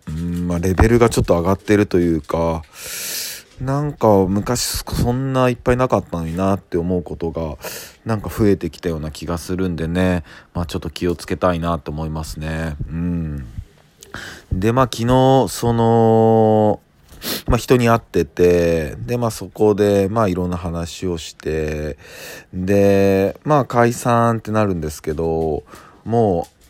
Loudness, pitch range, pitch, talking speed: -18 LUFS, 85-115 Hz, 95 Hz, 295 characters per minute